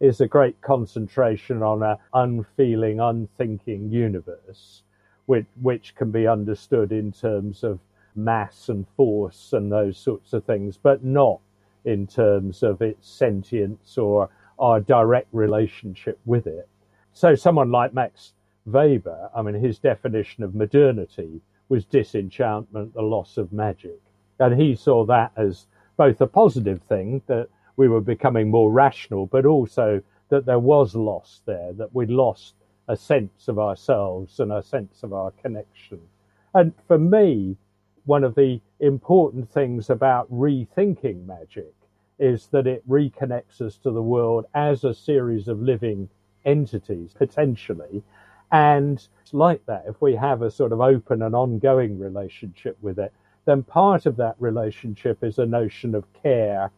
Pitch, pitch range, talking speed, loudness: 115 Hz, 105-130 Hz, 150 wpm, -21 LUFS